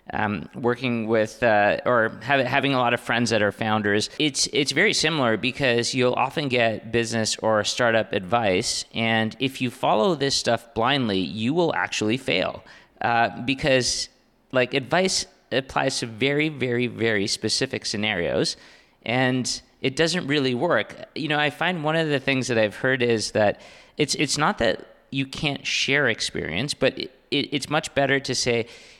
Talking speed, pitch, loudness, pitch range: 170 wpm, 125 Hz, -23 LUFS, 115-135 Hz